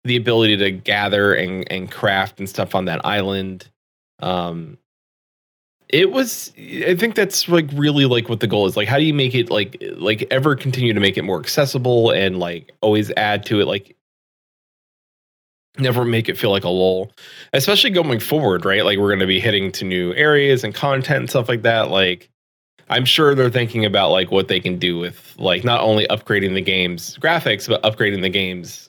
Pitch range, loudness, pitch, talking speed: 95-135 Hz, -17 LUFS, 110 Hz, 200 wpm